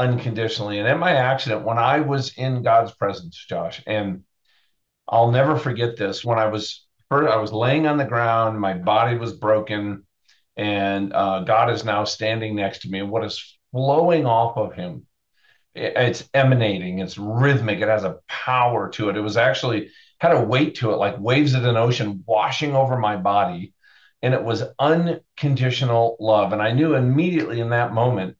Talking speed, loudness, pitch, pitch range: 185 wpm, -21 LUFS, 115 Hz, 105-130 Hz